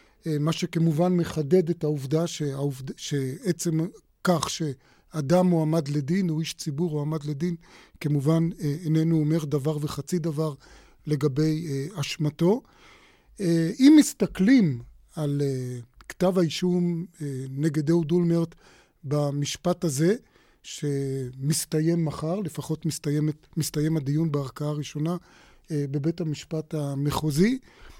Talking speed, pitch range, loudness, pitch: 95 wpm, 150-170 Hz, -26 LUFS, 160 Hz